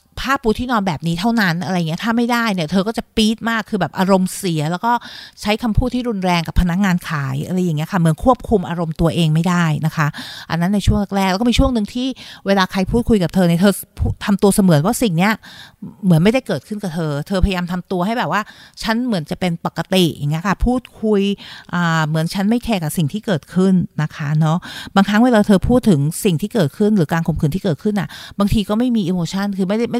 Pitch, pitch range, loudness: 190 Hz, 170-220 Hz, -17 LUFS